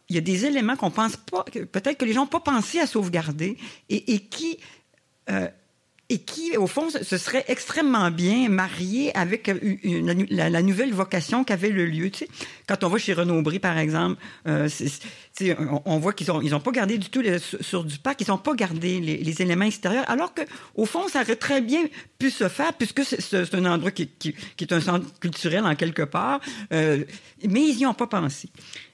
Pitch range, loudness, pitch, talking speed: 175-255 Hz, -24 LUFS, 195 Hz, 230 wpm